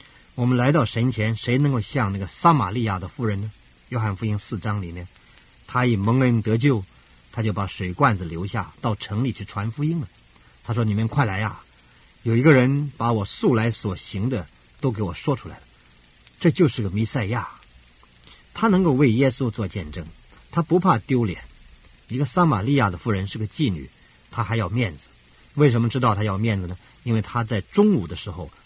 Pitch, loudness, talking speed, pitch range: 110 Hz, -23 LUFS, 280 characters per minute, 95-125 Hz